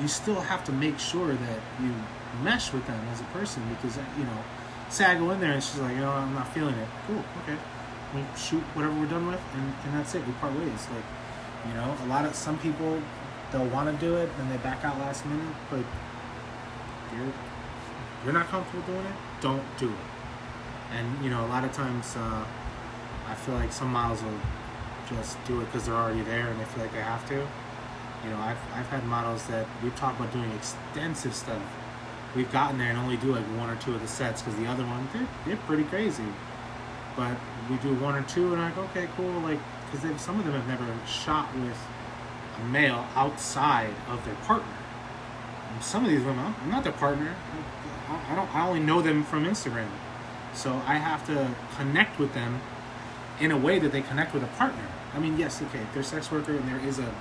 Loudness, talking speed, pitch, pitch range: -30 LUFS, 220 wpm, 130 Hz, 120-145 Hz